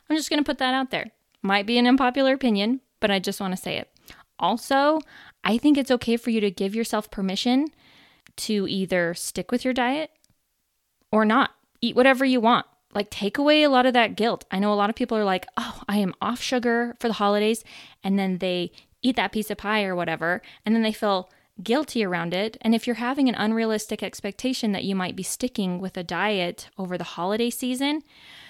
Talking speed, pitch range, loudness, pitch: 215 wpm, 195-250 Hz, -24 LUFS, 220 Hz